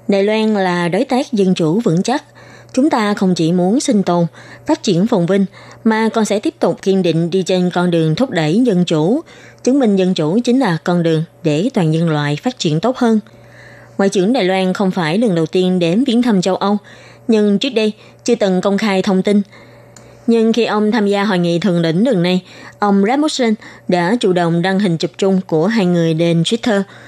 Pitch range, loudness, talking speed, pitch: 175-225 Hz, -15 LUFS, 220 wpm, 195 Hz